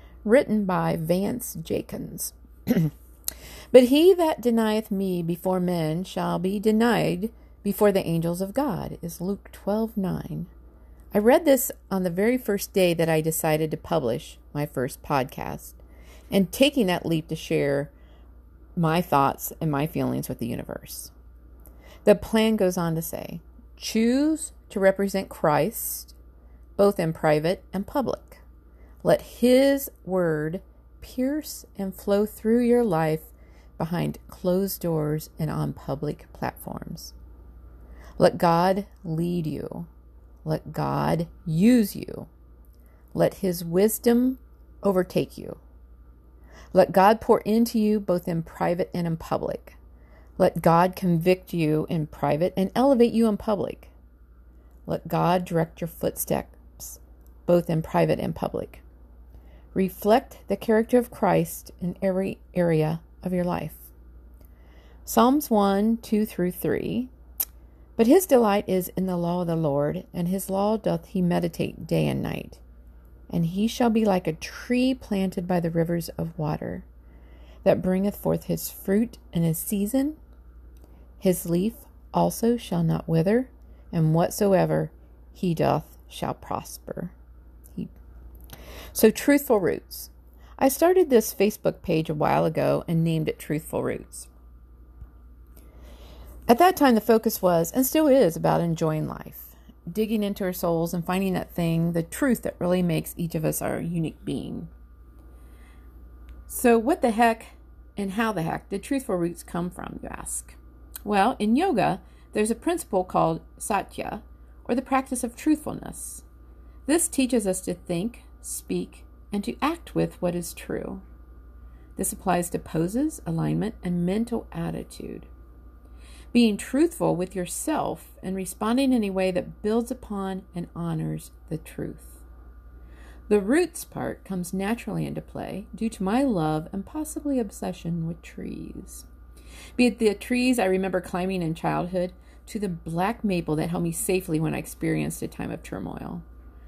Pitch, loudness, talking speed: 175 Hz, -25 LUFS, 145 wpm